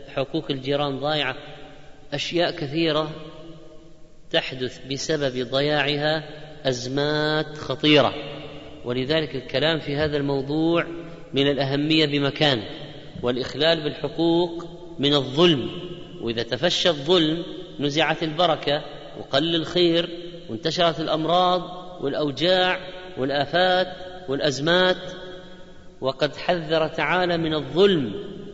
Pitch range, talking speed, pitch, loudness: 145-170 Hz, 80 wpm, 155 Hz, -23 LUFS